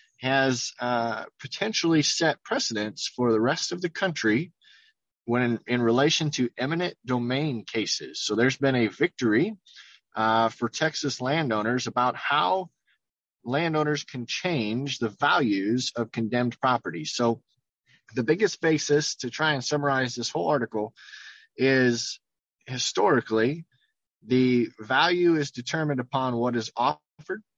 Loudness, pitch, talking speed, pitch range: -25 LUFS, 130 Hz, 130 wpm, 120-155 Hz